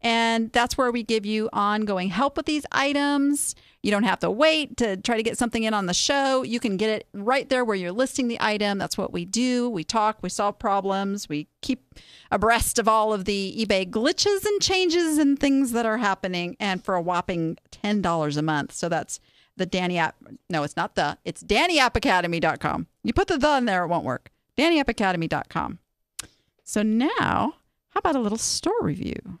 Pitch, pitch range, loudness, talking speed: 225 Hz, 190-265 Hz, -24 LUFS, 200 wpm